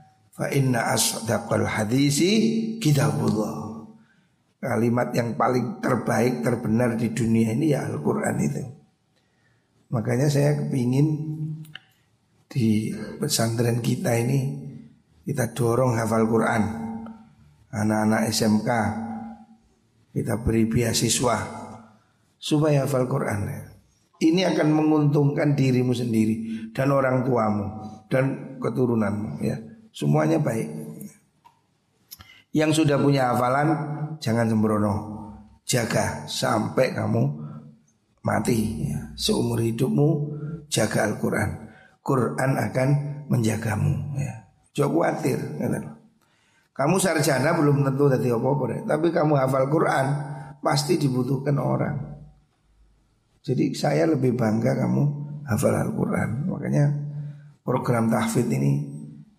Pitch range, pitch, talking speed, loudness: 110-145 Hz, 125 Hz, 85 wpm, -23 LUFS